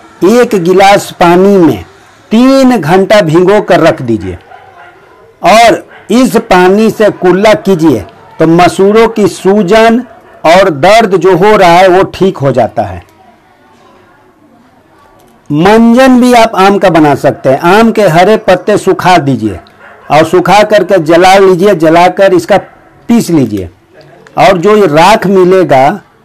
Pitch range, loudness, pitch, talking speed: 175-210 Hz, -5 LUFS, 190 Hz, 135 wpm